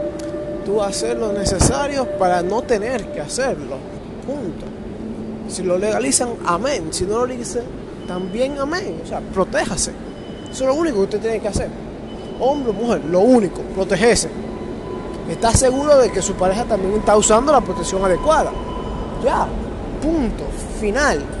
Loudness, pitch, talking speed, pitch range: -19 LUFS, 215 Hz, 150 wpm, 195-265 Hz